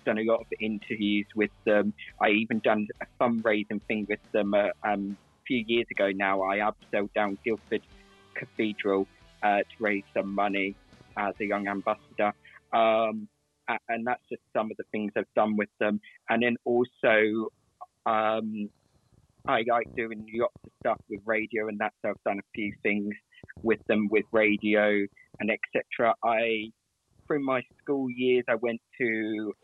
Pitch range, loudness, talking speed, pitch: 100-110 Hz, -28 LUFS, 165 wpm, 105 Hz